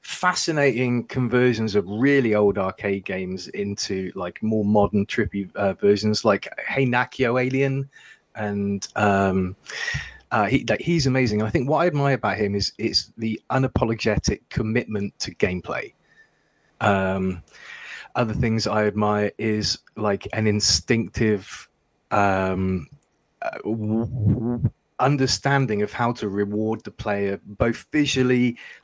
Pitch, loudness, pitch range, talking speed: 110 Hz, -23 LUFS, 100-125 Hz, 125 wpm